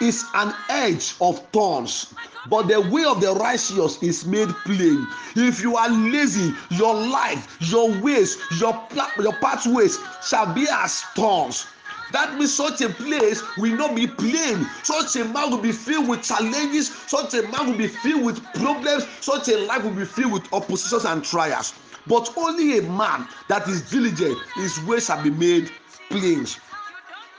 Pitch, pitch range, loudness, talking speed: 235 Hz, 205-285 Hz, -22 LUFS, 170 wpm